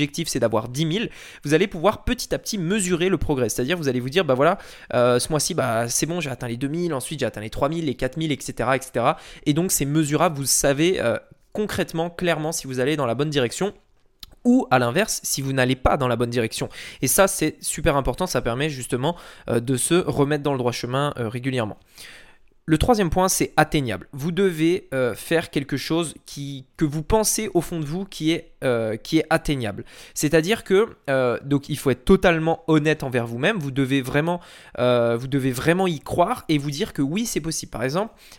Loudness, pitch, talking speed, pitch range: -22 LUFS, 150 Hz, 220 wpm, 130-175 Hz